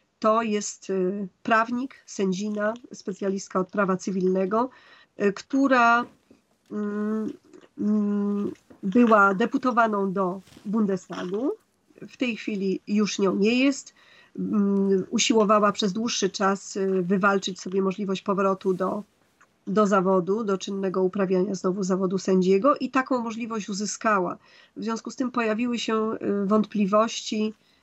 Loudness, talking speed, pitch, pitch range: -24 LUFS, 105 wpm, 205 Hz, 195-230 Hz